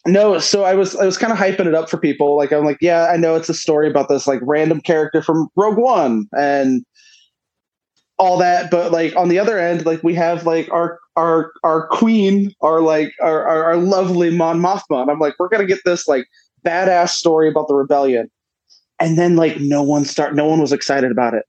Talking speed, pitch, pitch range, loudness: 220 wpm, 165 Hz, 150-180 Hz, -16 LUFS